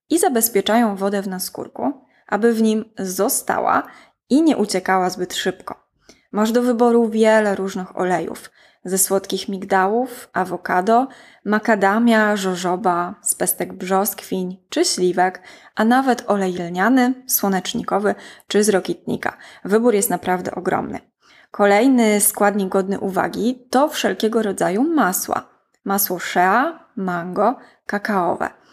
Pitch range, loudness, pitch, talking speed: 190-235 Hz, -19 LUFS, 205 Hz, 115 wpm